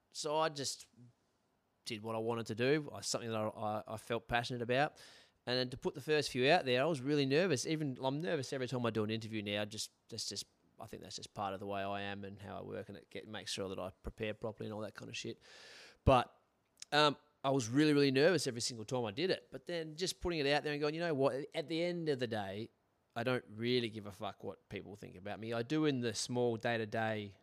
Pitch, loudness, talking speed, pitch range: 120 Hz, -37 LUFS, 270 wpm, 110-145 Hz